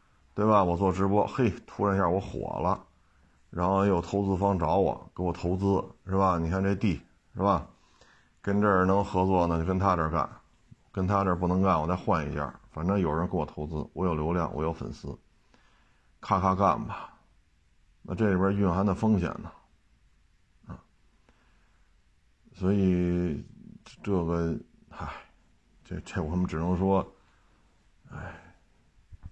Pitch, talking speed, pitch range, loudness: 90 Hz, 210 characters per minute, 85-95 Hz, -28 LUFS